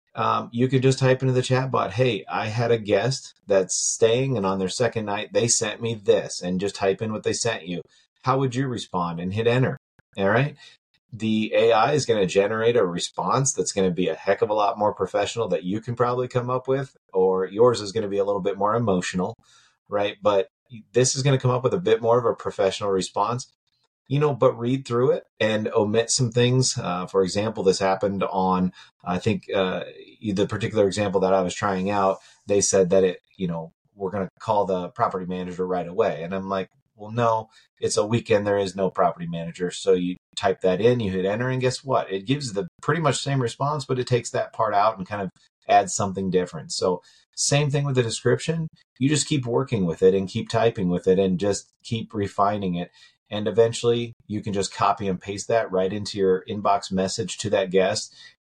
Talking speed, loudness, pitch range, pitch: 225 wpm, -23 LUFS, 95-130 Hz, 110 Hz